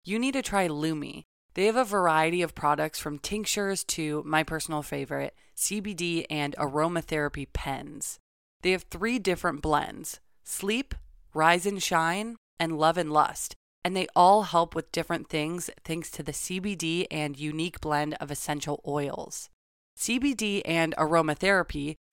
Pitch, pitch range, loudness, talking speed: 165 Hz, 150-190 Hz, -28 LUFS, 145 wpm